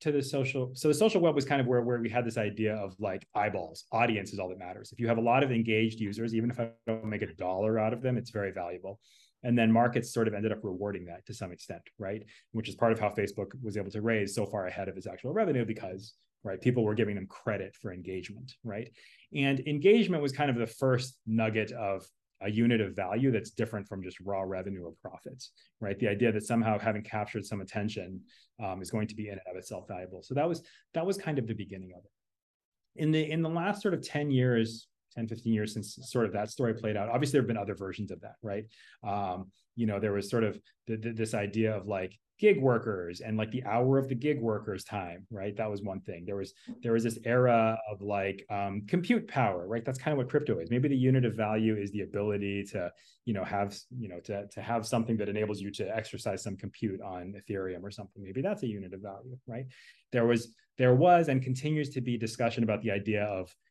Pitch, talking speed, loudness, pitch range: 110 Hz, 245 wpm, -31 LUFS, 100-125 Hz